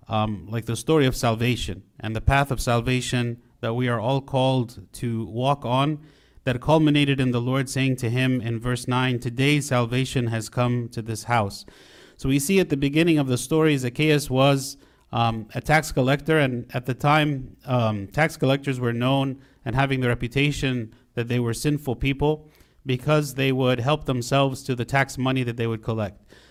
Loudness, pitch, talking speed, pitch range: -23 LUFS, 130 Hz, 190 wpm, 120-140 Hz